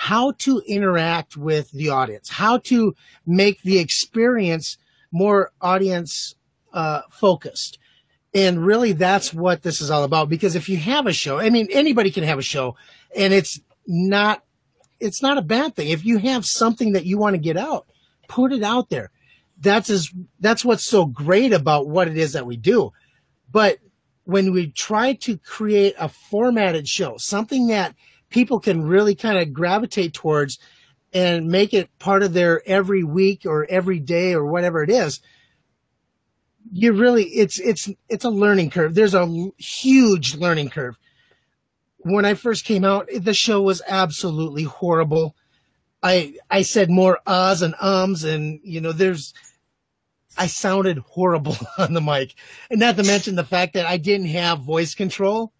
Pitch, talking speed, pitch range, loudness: 190 Hz, 165 wpm, 165-205 Hz, -19 LUFS